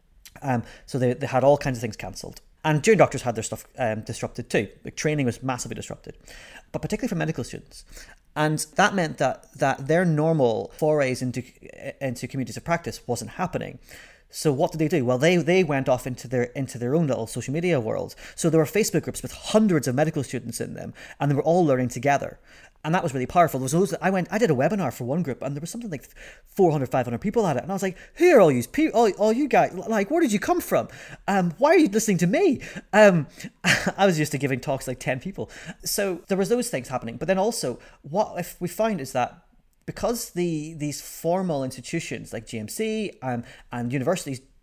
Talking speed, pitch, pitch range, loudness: 230 wpm, 155 Hz, 130-185 Hz, -24 LUFS